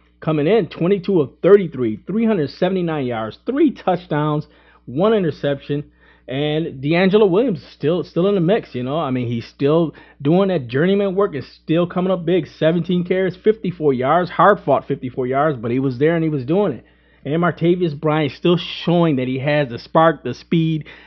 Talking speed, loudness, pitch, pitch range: 185 wpm, -18 LUFS, 160 Hz, 140-180 Hz